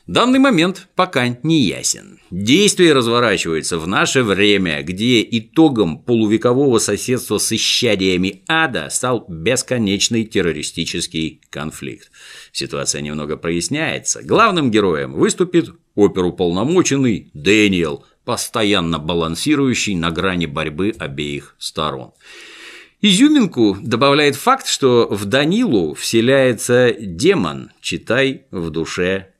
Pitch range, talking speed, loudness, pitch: 90-140 Hz, 95 wpm, -16 LUFS, 115 Hz